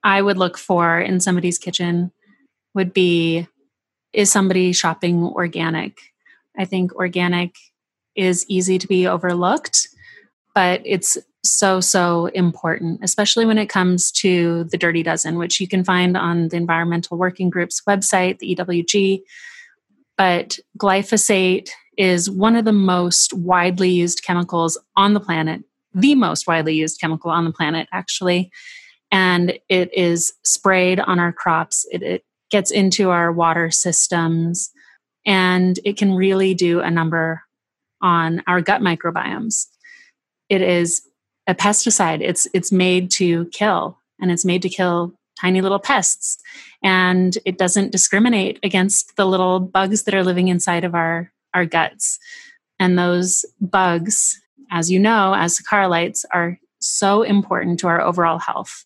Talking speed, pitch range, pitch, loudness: 145 wpm, 175-195 Hz, 185 Hz, -17 LUFS